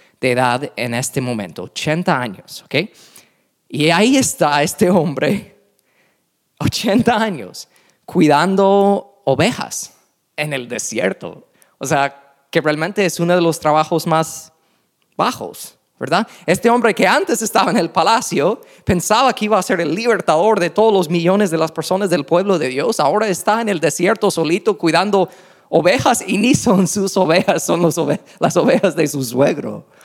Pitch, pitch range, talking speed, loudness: 175 Hz, 155-200 Hz, 160 wpm, -16 LUFS